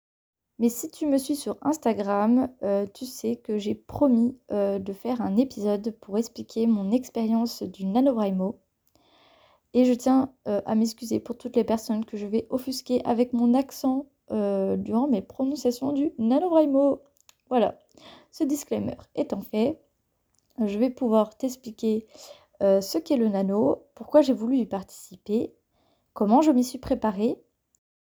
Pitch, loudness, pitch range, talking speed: 235 Hz, -26 LUFS, 215-265 Hz, 150 wpm